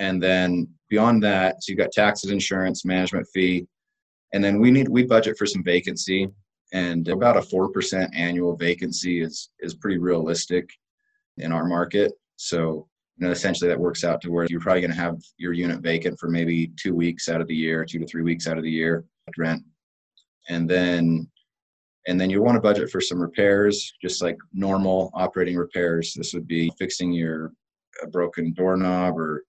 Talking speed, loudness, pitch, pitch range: 190 wpm, -23 LUFS, 90 Hz, 85-95 Hz